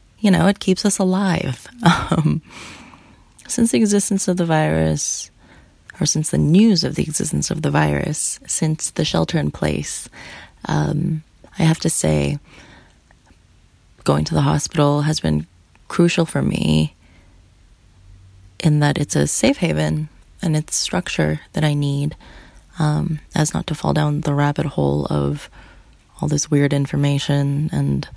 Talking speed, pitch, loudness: 145 wpm, 140 Hz, -19 LUFS